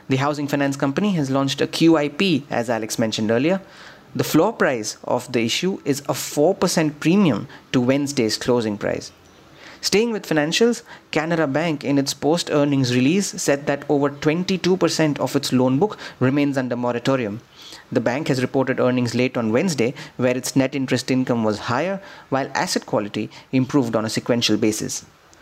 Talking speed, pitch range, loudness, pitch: 165 wpm, 125-155 Hz, -21 LUFS, 140 Hz